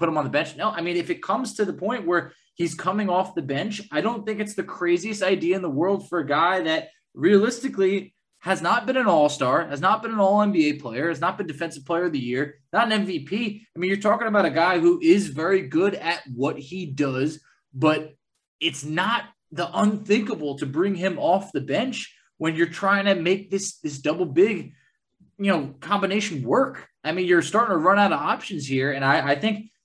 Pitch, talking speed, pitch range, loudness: 185 Hz, 225 wpm, 155-210 Hz, -23 LUFS